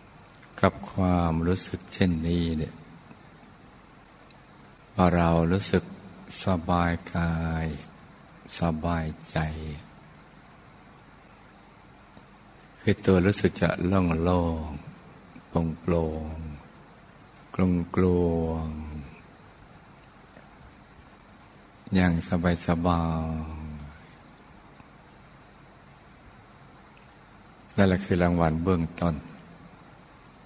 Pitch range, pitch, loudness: 80-90 Hz, 85 Hz, -27 LUFS